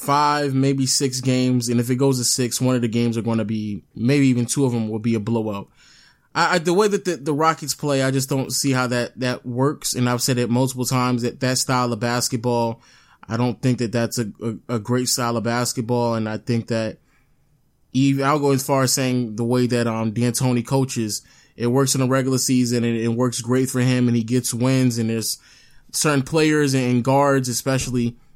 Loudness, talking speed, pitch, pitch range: -20 LUFS, 225 wpm, 125 Hz, 120-135 Hz